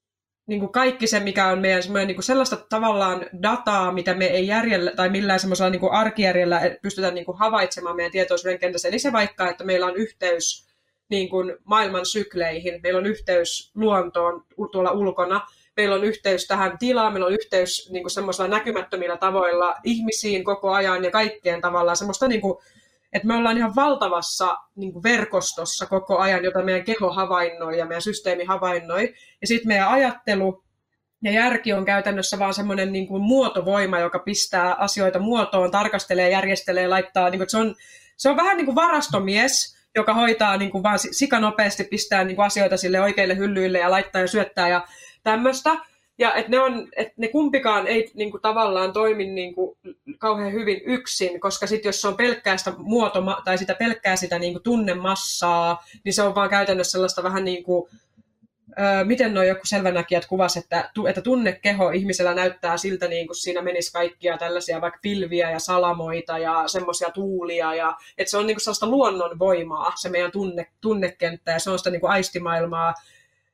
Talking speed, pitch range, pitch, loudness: 170 wpm, 180-210 Hz, 190 Hz, -22 LUFS